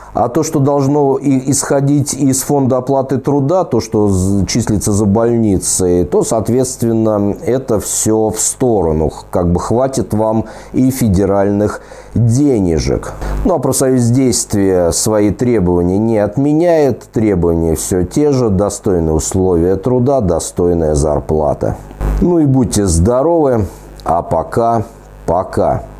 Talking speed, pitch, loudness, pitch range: 115 wpm, 110 Hz, -13 LUFS, 95-135 Hz